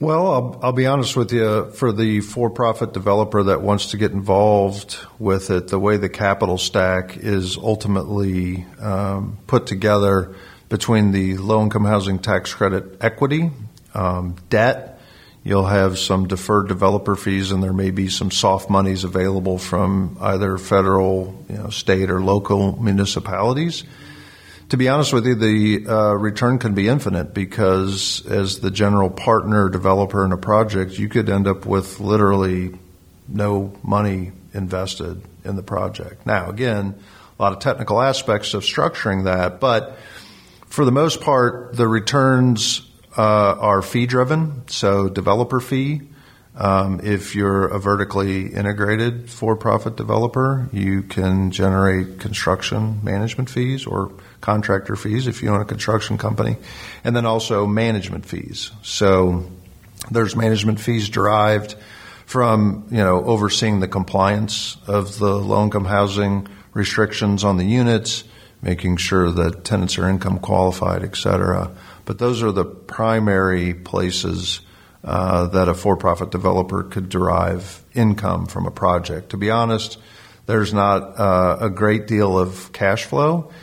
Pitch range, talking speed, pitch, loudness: 95-110 Hz, 145 wpm, 100 Hz, -19 LUFS